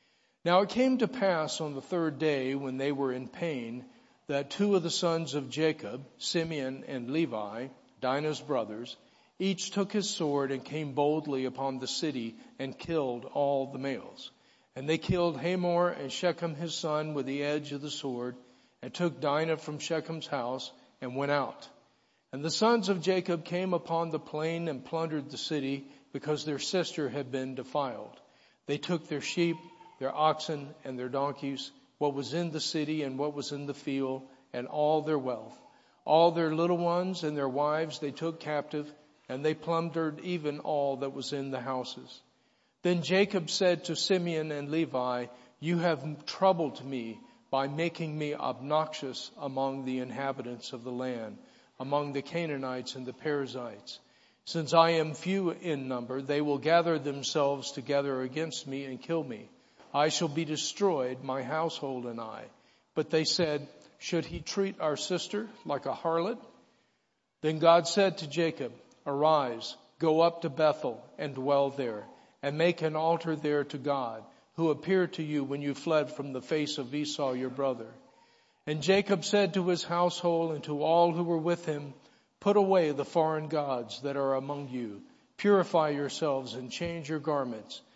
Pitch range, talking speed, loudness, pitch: 135-170 Hz, 170 wpm, -31 LUFS, 150 Hz